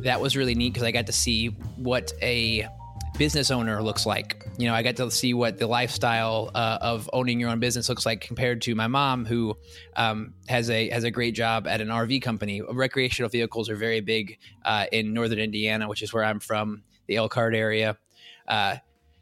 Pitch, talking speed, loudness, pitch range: 115 Hz, 205 wpm, -25 LUFS, 110-120 Hz